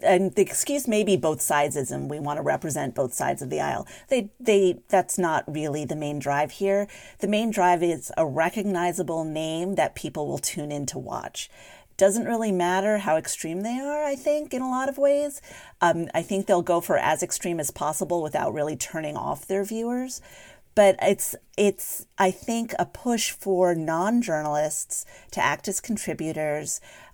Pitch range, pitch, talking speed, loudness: 160-210 Hz, 185 Hz, 185 wpm, -25 LUFS